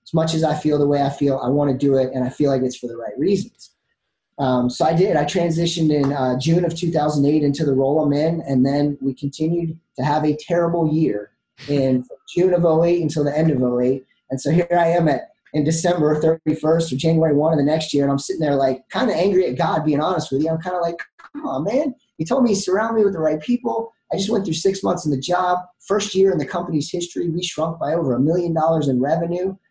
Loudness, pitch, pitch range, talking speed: -20 LUFS, 155 Hz, 140-175 Hz, 260 wpm